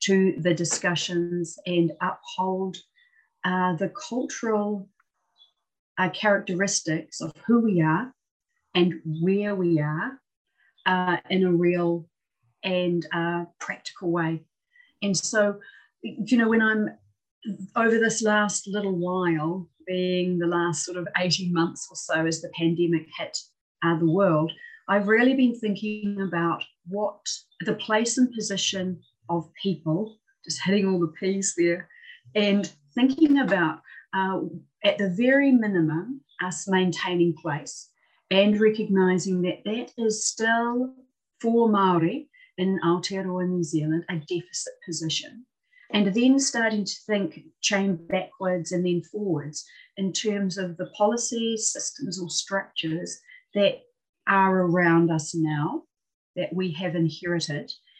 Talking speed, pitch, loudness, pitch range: 130 wpm, 190 Hz, -25 LUFS, 170-215 Hz